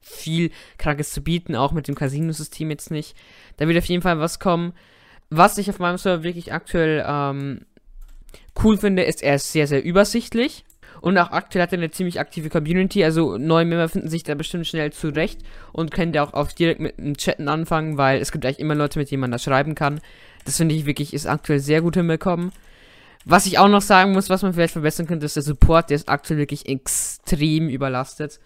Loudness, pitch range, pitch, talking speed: -21 LUFS, 145-175 Hz, 160 Hz, 215 wpm